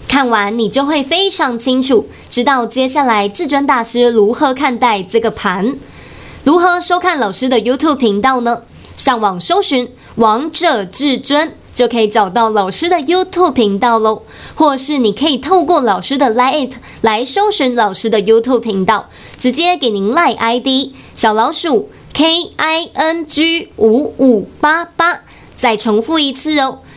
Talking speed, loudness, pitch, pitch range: 285 characters per minute, -12 LUFS, 260 Hz, 225-310 Hz